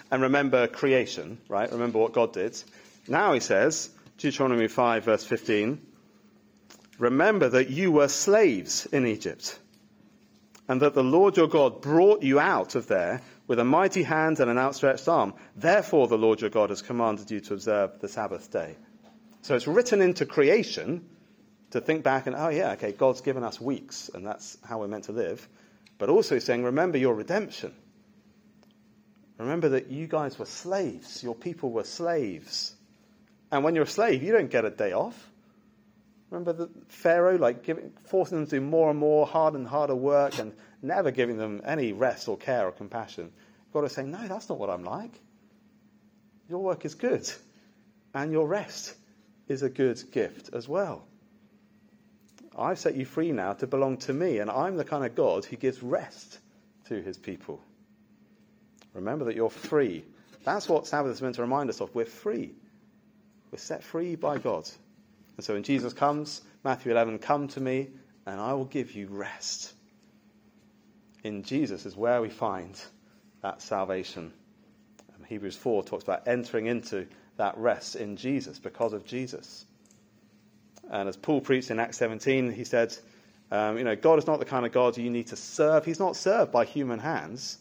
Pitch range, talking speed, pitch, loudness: 125-210 Hz, 180 wpm, 145 Hz, -27 LUFS